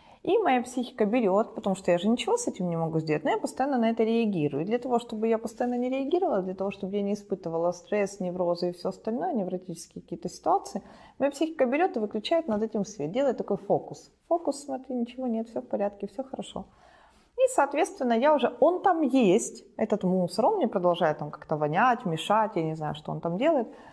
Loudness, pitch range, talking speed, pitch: -27 LUFS, 185-265 Hz, 215 wpm, 225 Hz